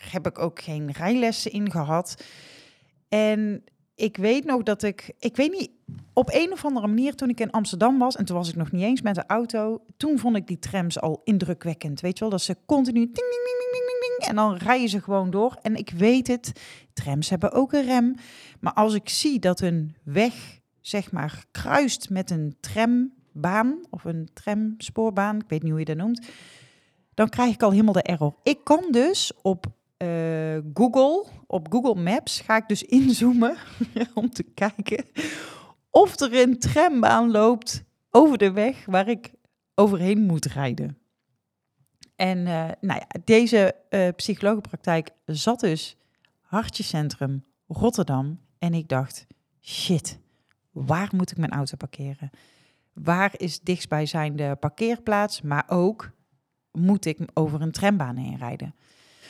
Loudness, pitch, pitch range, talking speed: -24 LUFS, 195 Hz, 160-230 Hz, 170 wpm